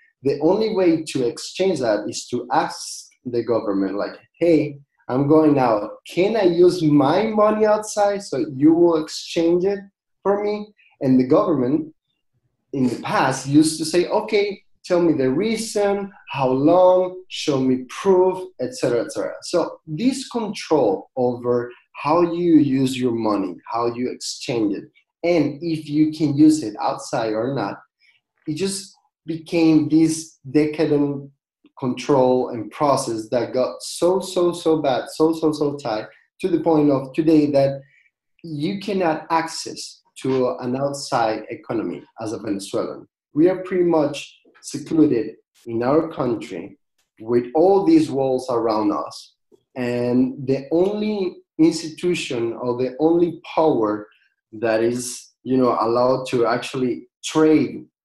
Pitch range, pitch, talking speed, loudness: 130-180 Hz, 155 Hz, 145 wpm, -20 LUFS